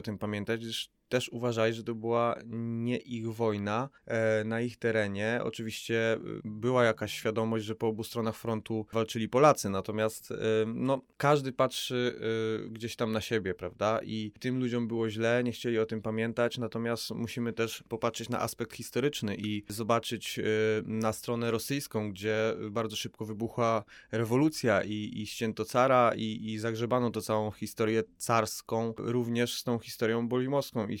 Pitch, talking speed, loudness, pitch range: 115 Hz, 170 wpm, -31 LUFS, 110-120 Hz